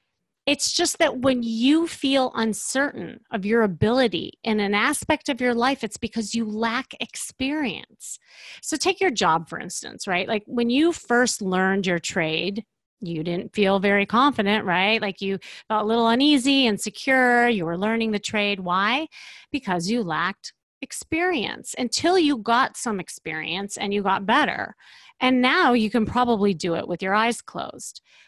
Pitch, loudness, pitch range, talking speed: 230 Hz, -22 LUFS, 200-270 Hz, 170 wpm